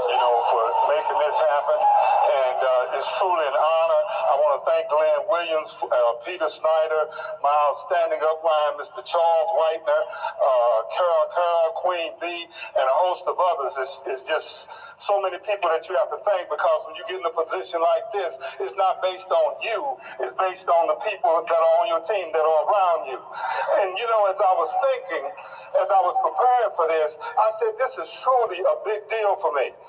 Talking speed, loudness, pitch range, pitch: 200 wpm, -22 LUFS, 160-255 Hz, 185 Hz